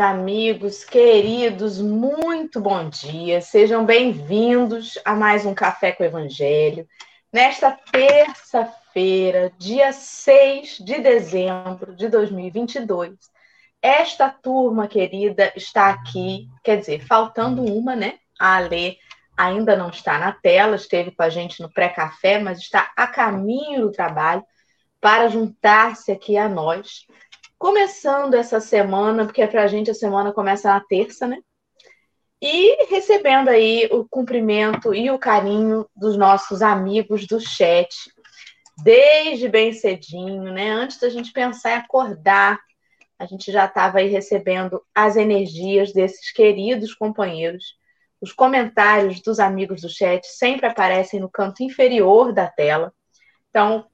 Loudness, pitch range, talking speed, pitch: -18 LUFS, 195-245 Hz, 130 wpm, 210 Hz